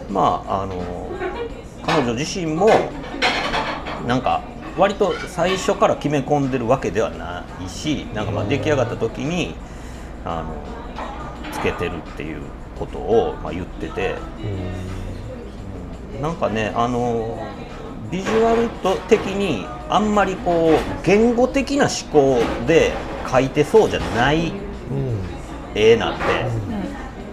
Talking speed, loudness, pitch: 225 characters per minute, -21 LUFS, 115 Hz